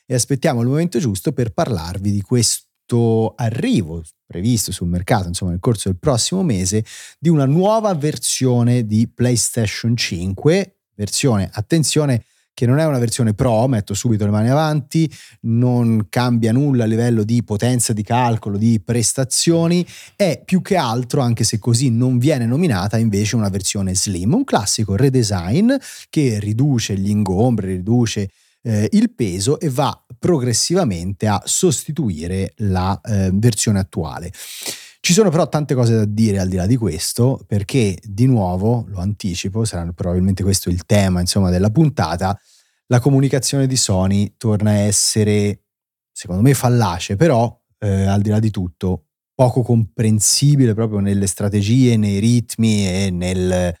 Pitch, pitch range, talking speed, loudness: 115 Hz, 100-130 Hz, 150 wpm, -17 LUFS